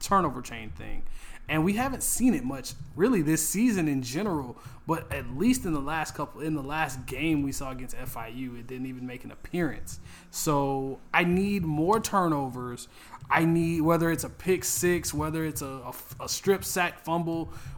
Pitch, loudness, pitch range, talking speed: 150 Hz, -28 LUFS, 130-170 Hz, 185 wpm